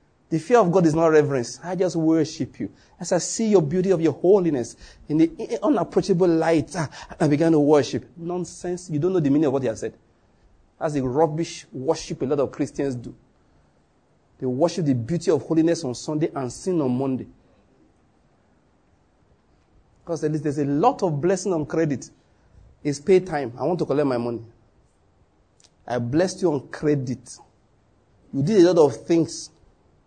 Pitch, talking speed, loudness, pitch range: 155 Hz, 175 wpm, -22 LUFS, 130-175 Hz